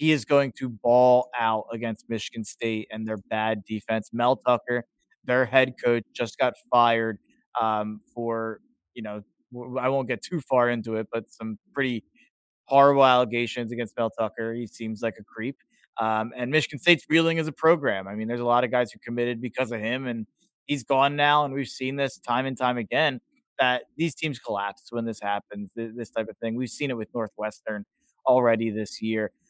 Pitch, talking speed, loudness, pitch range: 120 Hz, 195 wpm, -25 LUFS, 110-130 Hz